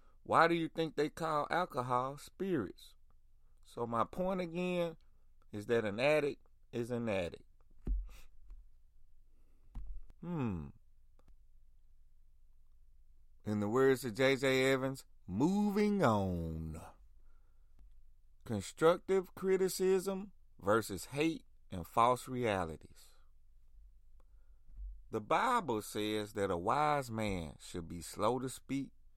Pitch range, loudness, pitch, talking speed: 90-145 Hz, -35 LUFS, 110 Hz, 95 wpm